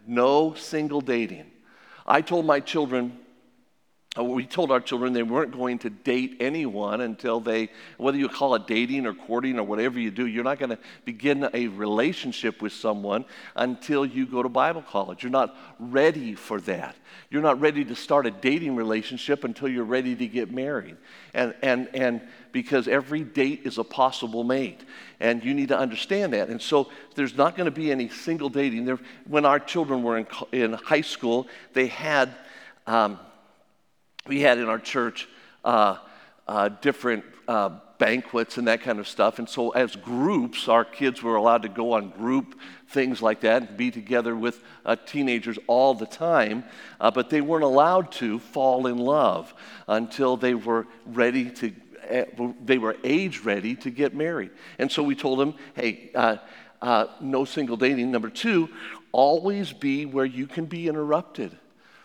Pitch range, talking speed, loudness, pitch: 115-140 Hz, 175 wpm, -25 LUFS, 125 Hz